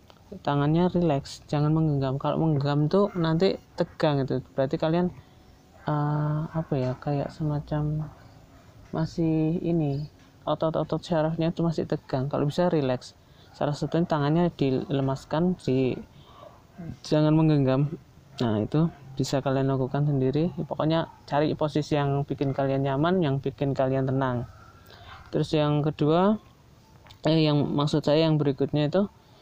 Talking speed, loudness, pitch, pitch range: 125 wpm, -26 LUFS, 150 Hz, 135-160 Hz